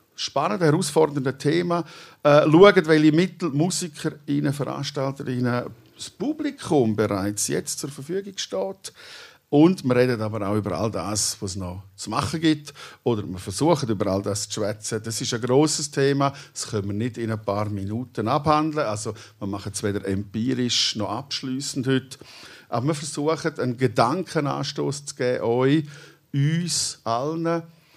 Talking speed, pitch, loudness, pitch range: 150 wpm, 135 Hz, -23 LUFS, 110-155 Hz